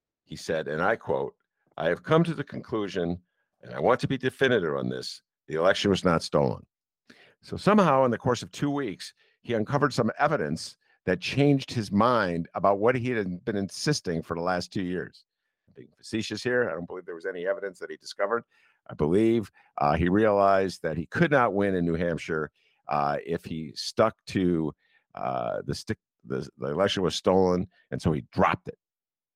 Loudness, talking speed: -27 LUFS, 195 wpm